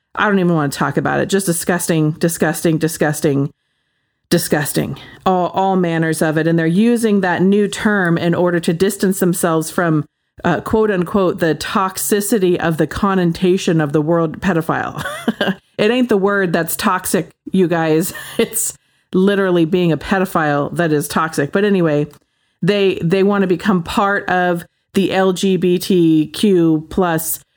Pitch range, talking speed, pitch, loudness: 160-195 Hz, 150 wpm, 180 Hz, -16 LUFS